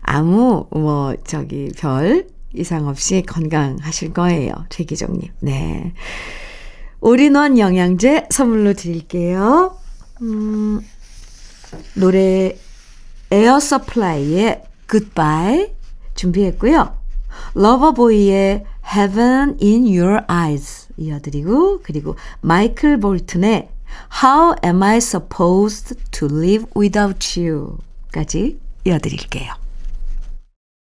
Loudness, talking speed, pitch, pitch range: -16 LUFS, 250 characters per minute, 190 Hz, 165-230 Hz